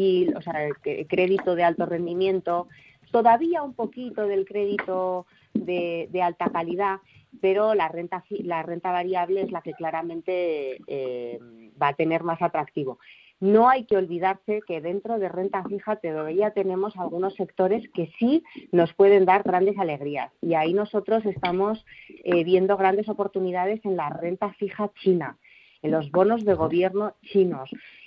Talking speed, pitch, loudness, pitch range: 150 wpm, 185 Hz, -25 LUFS, 170-205 Hz